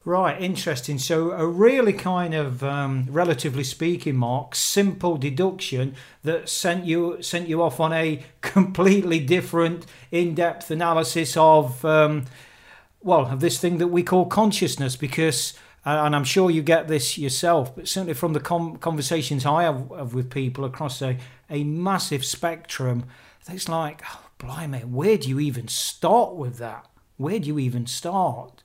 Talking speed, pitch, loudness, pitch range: 155 wpm, 160 Hz, -23 LUFS, 140-175 Hz